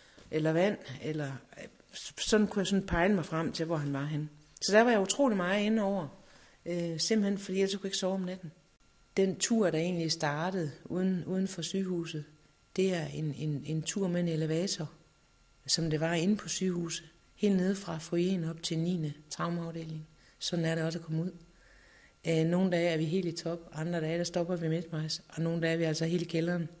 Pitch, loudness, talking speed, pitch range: 170 Hz, -32 LUFS, 210 wpm, 160-185 Hz